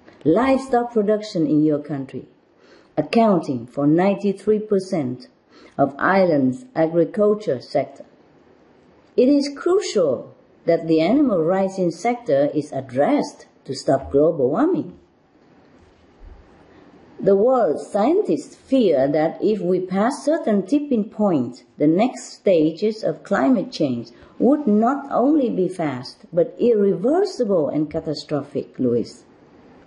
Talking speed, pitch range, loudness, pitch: 105 wpm, 155-240 Hz, -20 LUFS, 195 Hz